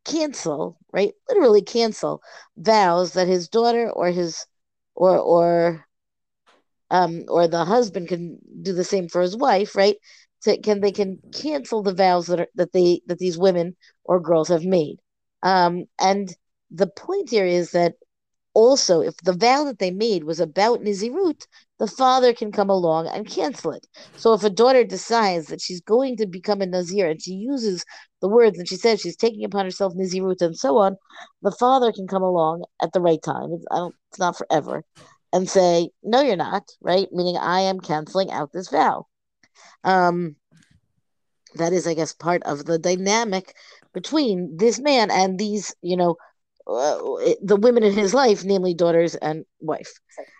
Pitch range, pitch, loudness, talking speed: 175-220 Hz, 190 Hz, -21 LUFS, 175 wpm